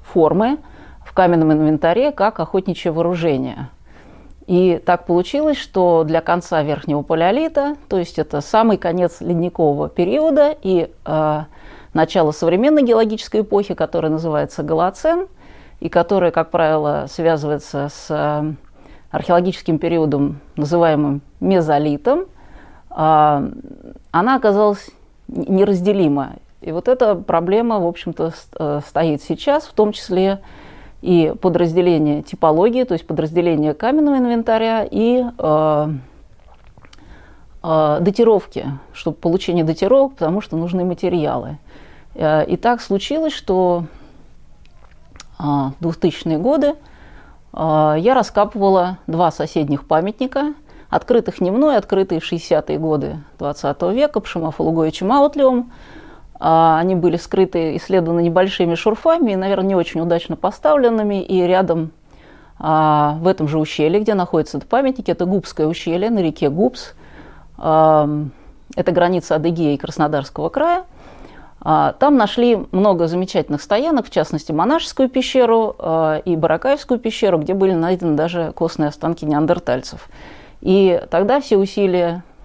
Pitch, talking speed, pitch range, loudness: 175 Hz, 115 wpm, 155-210 Hz, -17 LUFS